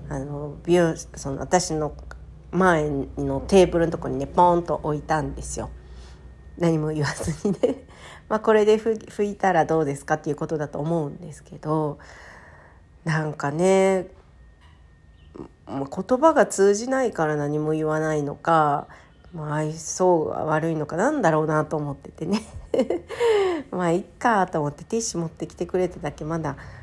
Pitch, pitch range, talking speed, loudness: 155 Hz, 145-180 Hz, 280 characters per minute, -23 LUFS